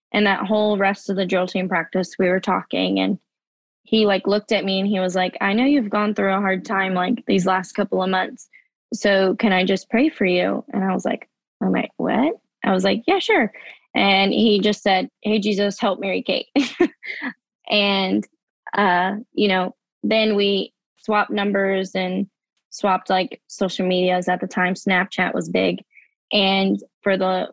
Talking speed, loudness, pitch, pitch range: 190 wpm, -20 LUFS, 195 Hz, 185-215 Hz